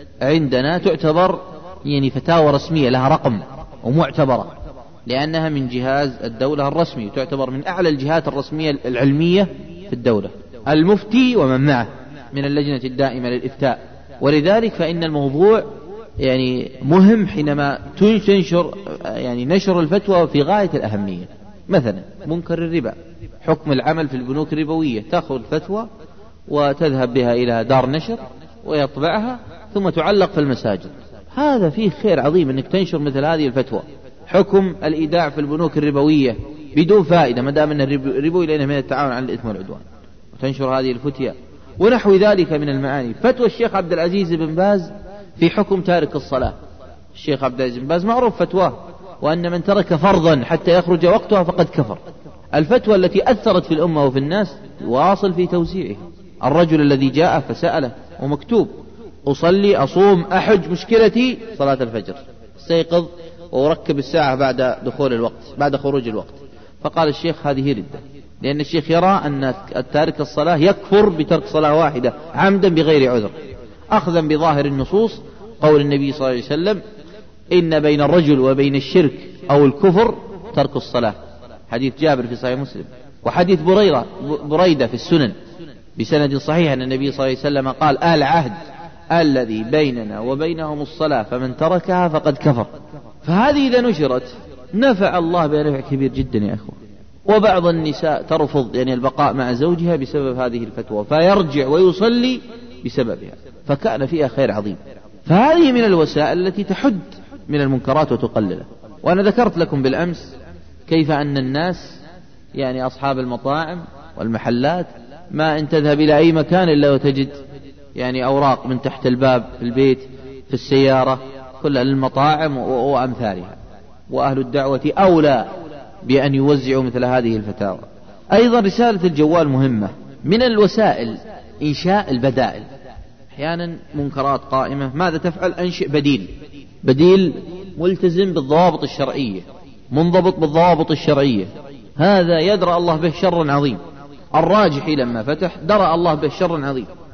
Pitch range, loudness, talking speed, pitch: 130-175 Hz, -17 LUFS, 130 wpm, 150 Hz